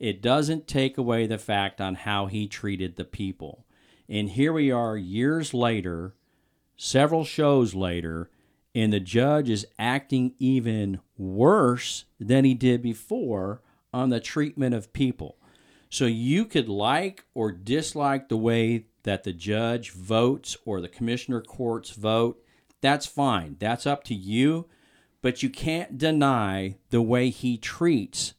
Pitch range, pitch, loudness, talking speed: 105-135 Hz, 120 Hz, -26 LUFS, 145 wpm